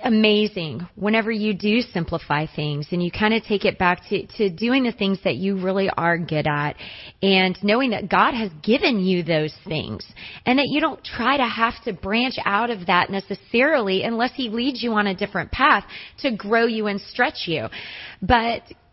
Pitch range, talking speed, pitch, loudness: 180-235 Hz, 195 wpm, 205 Hz, -21 LUFS